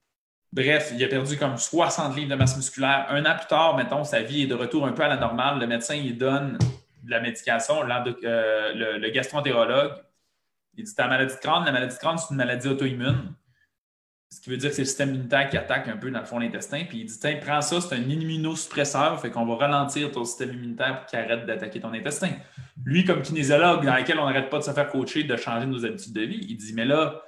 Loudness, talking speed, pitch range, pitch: -25 LUFS, 245 wpm, 125-150 Hz, 135 Hz